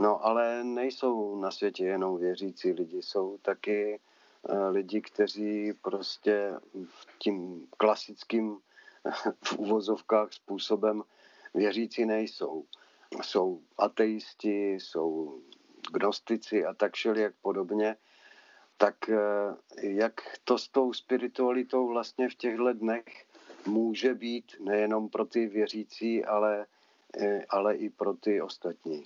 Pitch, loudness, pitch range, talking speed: 110 Hz, -31 LUFS, 105-120 Hz, 105 wpm